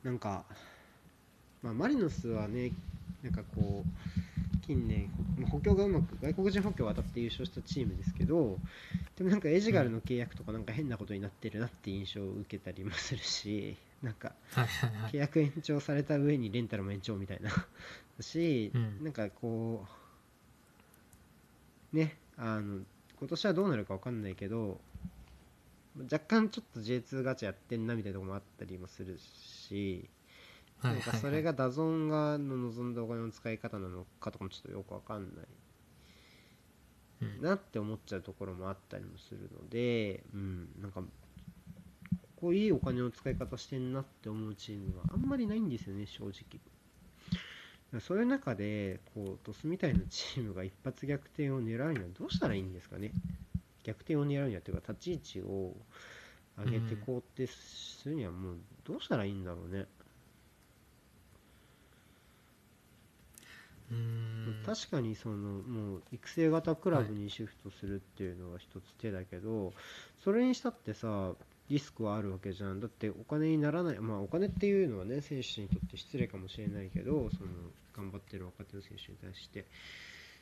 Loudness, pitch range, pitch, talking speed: -37 LUFS, 100-135 Hz, 110 Hz, 330 characters per minute